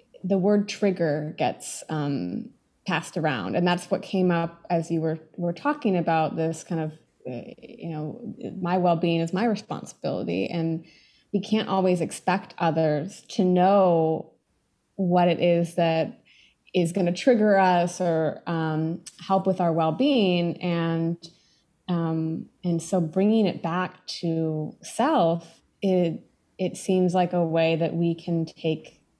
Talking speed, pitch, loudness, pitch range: 150 wpm, 175 Hz, -25 LUFS, 165-190 Hz